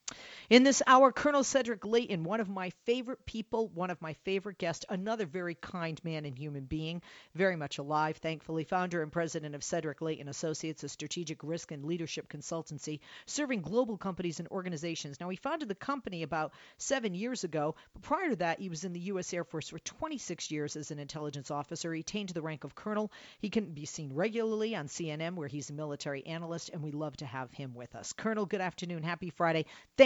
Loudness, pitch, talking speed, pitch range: -34 LUFS, 170 Hz, 210 wpm, 155-205 Hz